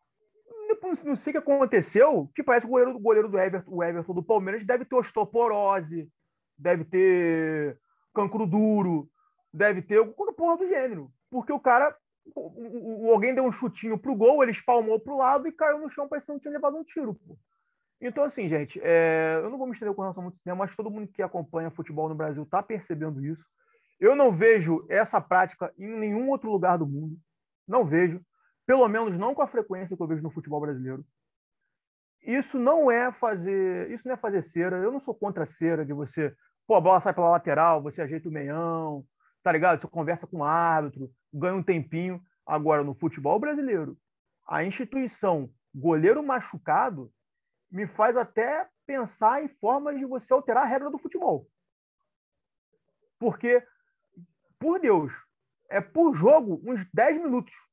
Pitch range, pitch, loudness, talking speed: 170-260 Hz, 215 Hz, -26 LUFS, 180 wpm